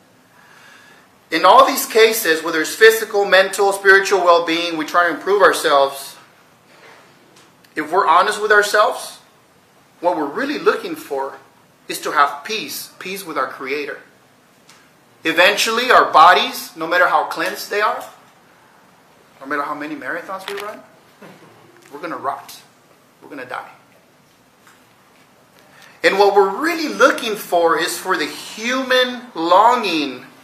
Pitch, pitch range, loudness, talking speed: 200 Hz, 170-245 Hz, -16 LUFS, 135 wpm